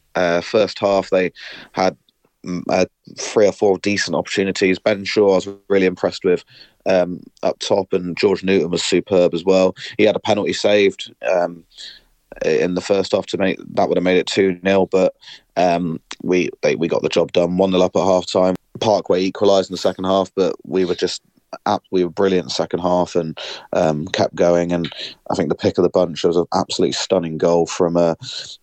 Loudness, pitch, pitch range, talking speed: -18 LUFS, 90 Hz, 85-95 Hz, 205 wpm